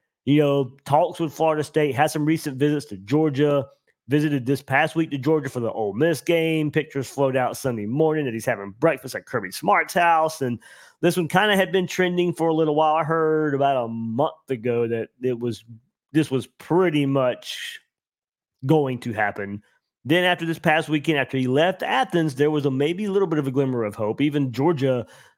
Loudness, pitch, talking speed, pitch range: -22 LUFS, 145 Hz, 205 wpm, 130-160 Hz